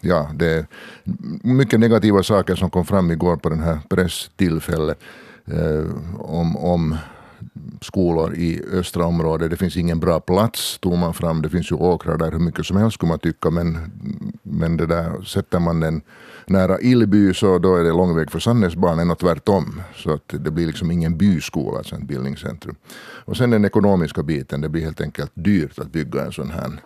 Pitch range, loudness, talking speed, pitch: 80-95 Hz, -20 LUFS, 190 wpm, 85 Hz